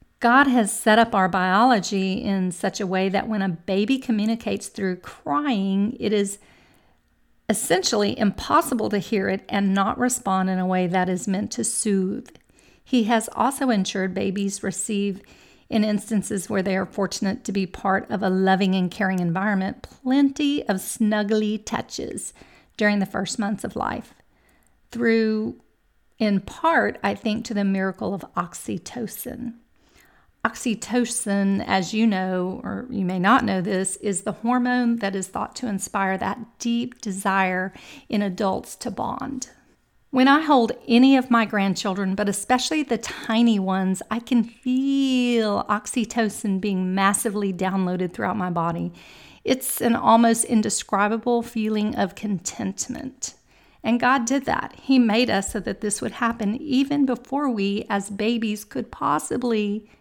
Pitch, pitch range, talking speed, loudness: 210 Hz, 195-240 Hz, 150 wpm, -23 LUFS